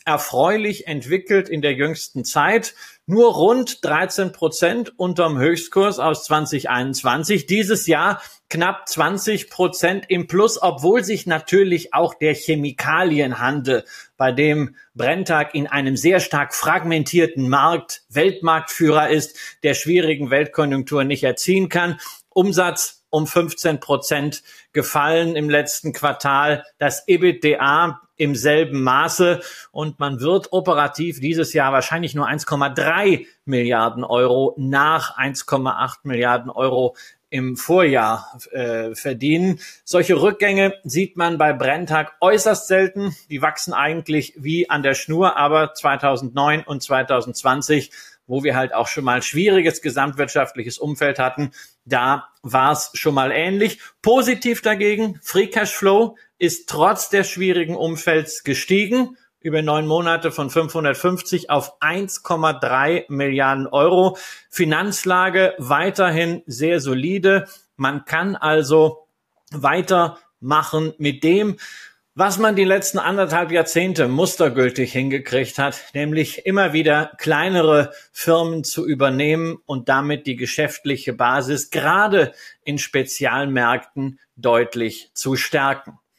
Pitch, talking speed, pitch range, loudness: 155 Hz, 115 wpm, 140-180 Hz, -19 LUFS